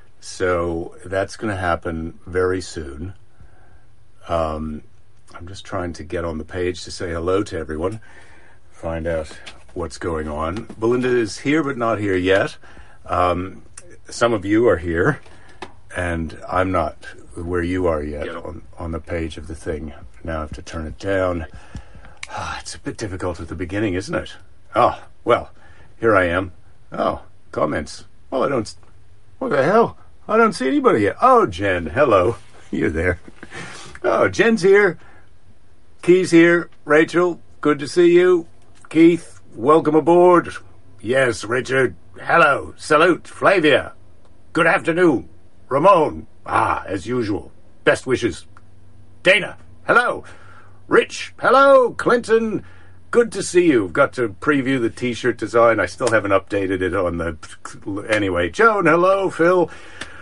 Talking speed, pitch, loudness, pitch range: 145 wpm, 95 Hz, -19 LUFS, 85-140 Hz